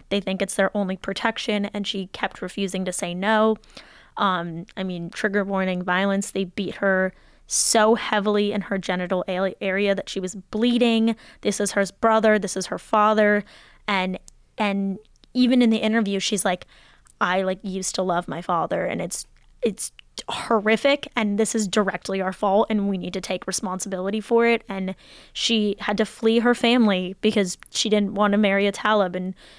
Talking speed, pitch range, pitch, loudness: 180 wpm, 190-215 Hz, 200 Hz, -23 LUFS